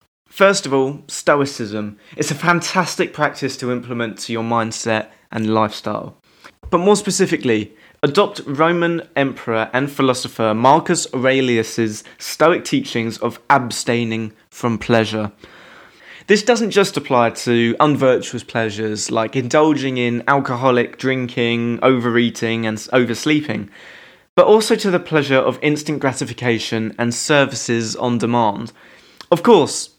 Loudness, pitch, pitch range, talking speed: -17 LUFS, 125 Hz, 115-150 Hz, 120 wpm